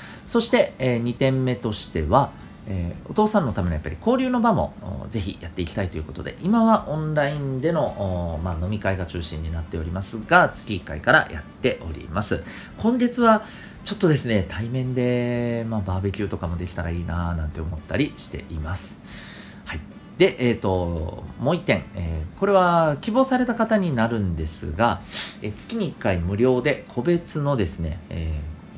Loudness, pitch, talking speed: -23 LUFS, 110 Hz, 355 characters per minute